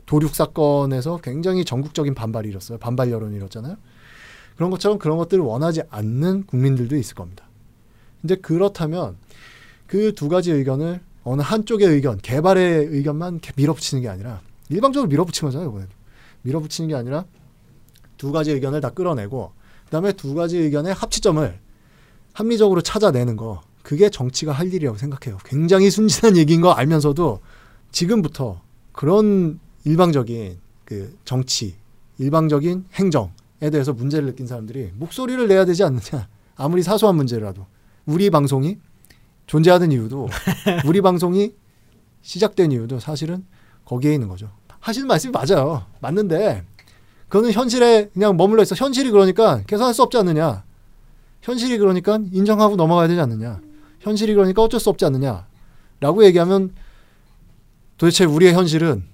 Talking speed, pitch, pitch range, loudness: 360 characters per minute, 150 Hz, 120-185 Hz, -18 LUFS